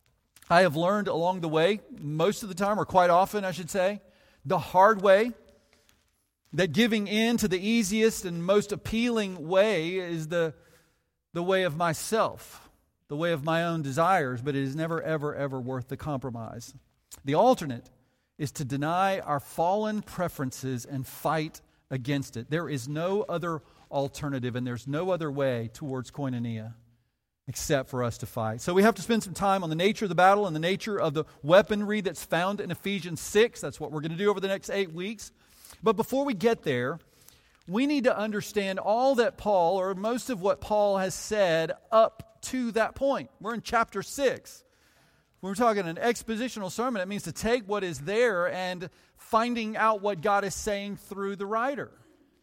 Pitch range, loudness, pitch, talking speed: 150-210 Hz, -27 LUFS, 185 Hz, 190 wpm